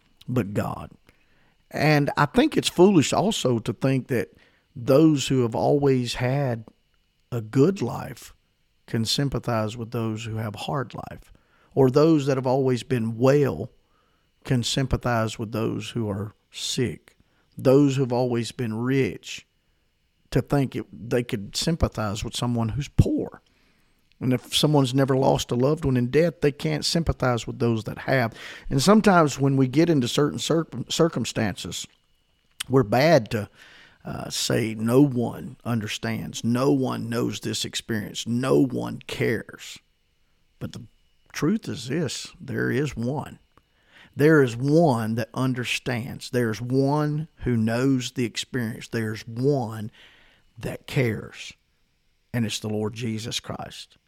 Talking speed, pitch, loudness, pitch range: 145 wpm, 125 Hz, -24 LUFS, 115-140 Hz